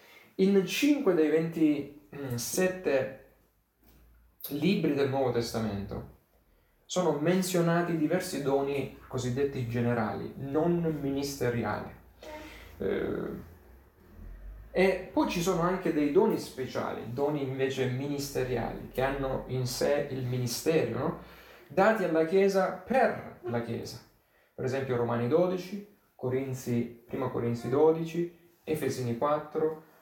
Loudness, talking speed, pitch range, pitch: -30 LUFS, 100 wpm, 120-170 Hz, 140 Hz